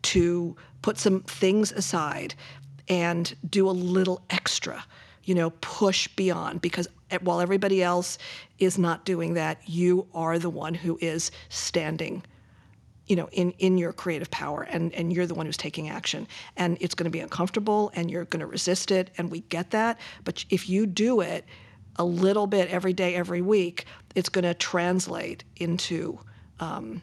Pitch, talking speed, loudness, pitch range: 175 Hz, 175 wpm, -27 LUFS, 170-185 Hz